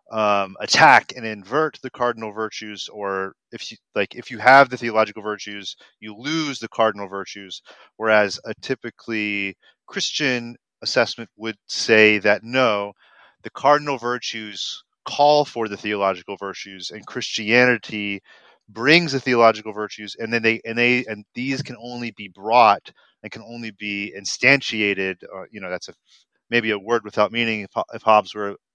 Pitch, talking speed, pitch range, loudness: 110 Hz, 155 wpm, 105-120 Hz, -20 LUFS